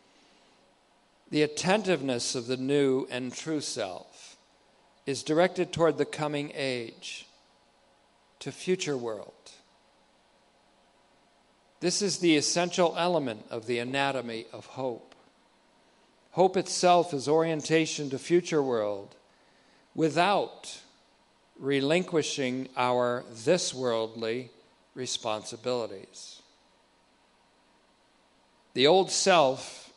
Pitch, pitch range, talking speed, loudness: 140 Hz, 125-165 Hz, 85 wpm, -28 LUFS